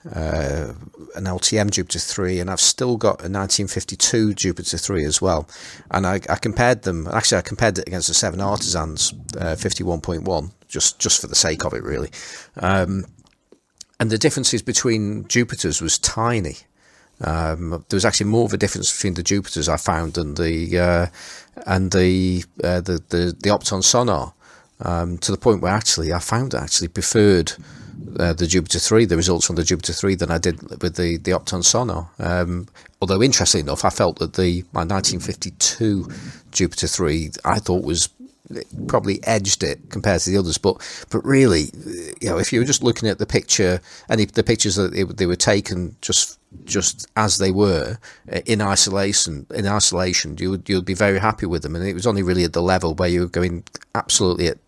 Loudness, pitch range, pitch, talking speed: -19 LUFS, 85-105 Hz, 95 Hz, 195 wpm